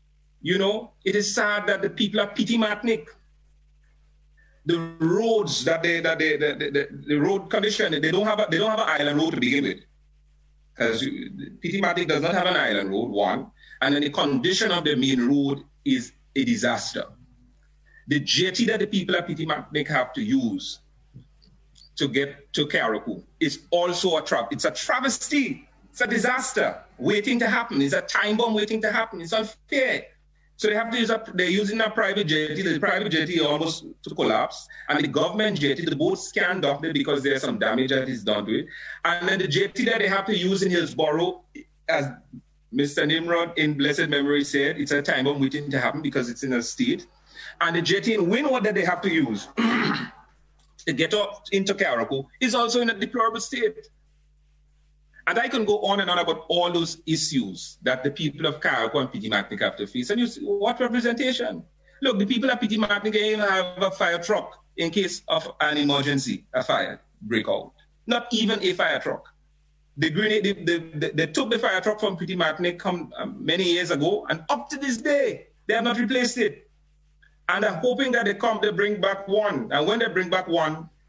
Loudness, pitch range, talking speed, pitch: -24 LUFS, 150-220 Hz, 200 wpm, 180 Hz